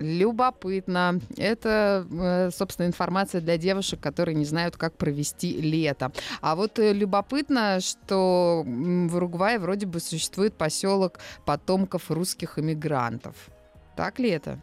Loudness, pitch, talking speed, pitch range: -26 LUFS, 180 Hz, 115 wpm, 160-195 Hz